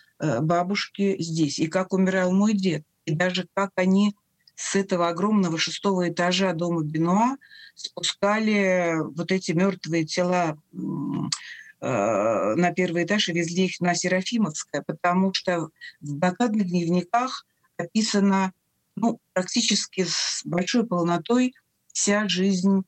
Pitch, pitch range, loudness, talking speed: 185 Hz, 175-200 Hz, -24 LUFS, 115 wpm